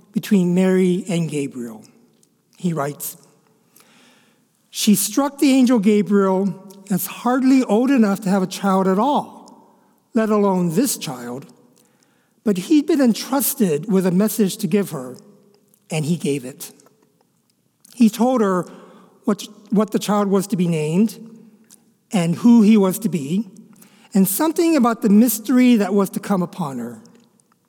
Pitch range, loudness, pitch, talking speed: 185-230 Hz, -18 LUFS, 210 Hz, 145 wpm